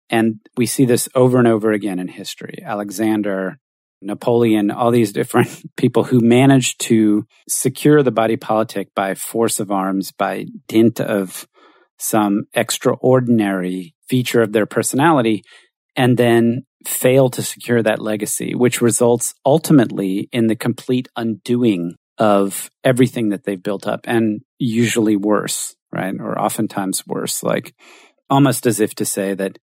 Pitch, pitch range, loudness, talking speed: 110 Hz, 105-120 Hz, -17 LUFS, 140 wpm